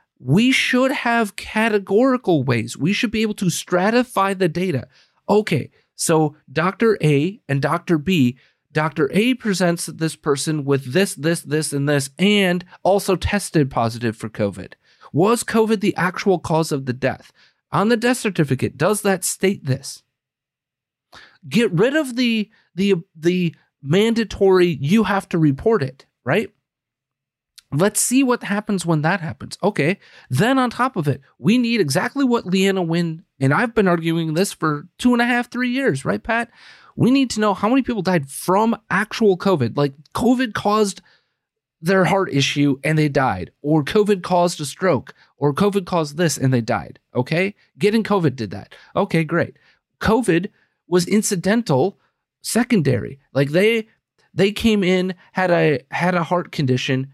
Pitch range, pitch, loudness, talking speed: 145-210 Hz, 180 Hz, -19 LUFS, 160 wpm